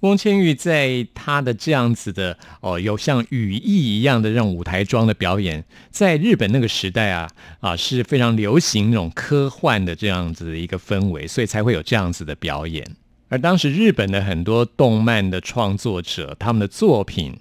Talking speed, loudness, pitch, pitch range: 285 characters per minute, -19 LUFS, 110 Hz, 90-125 Hz